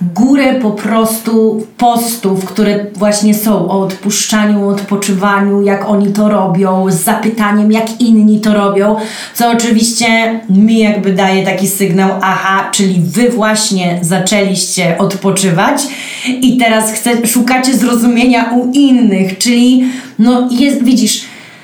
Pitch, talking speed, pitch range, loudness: 215 Hz, 120 wpm, 195-235 Hz, -10 LUFS